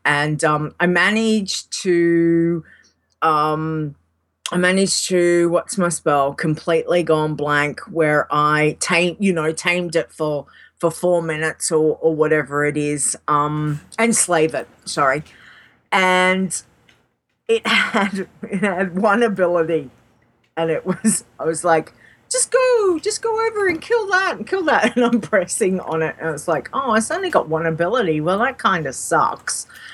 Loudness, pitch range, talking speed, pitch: -18 LUFS, 155-200 Hz, 160 wpm, 170 Hz